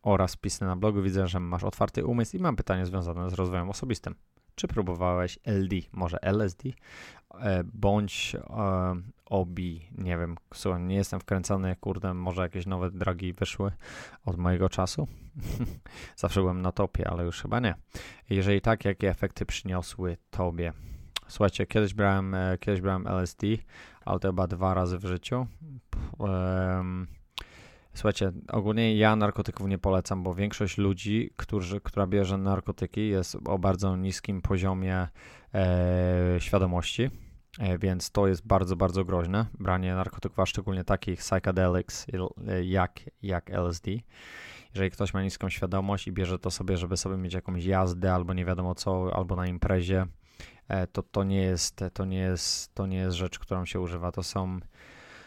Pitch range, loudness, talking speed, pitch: 90-100 Hz, -30 LUFS, 155 wpm, 95 Hz